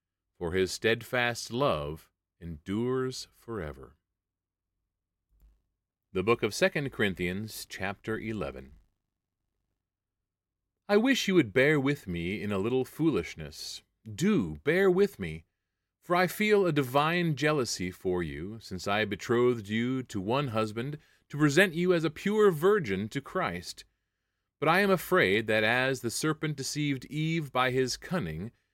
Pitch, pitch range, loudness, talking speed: 110 Hz, 95-145 Hz, -29 LUFS, 135 wpm